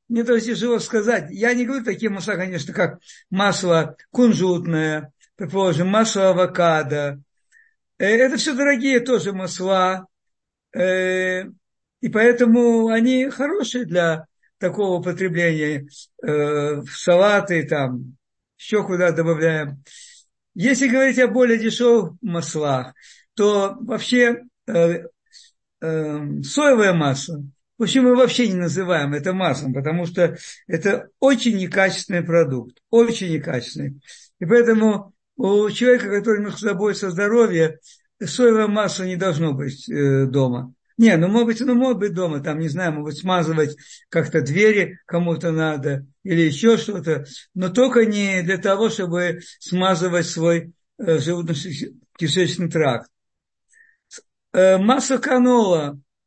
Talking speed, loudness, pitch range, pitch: 115 wpm, -19 LUFS, 160-225 Hz, 185 Hz